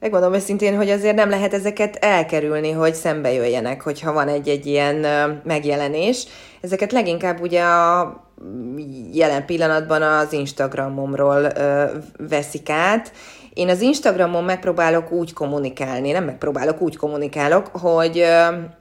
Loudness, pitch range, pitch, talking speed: -19 LUFS, 145-180 Hz, 155 Hz, 120 wpm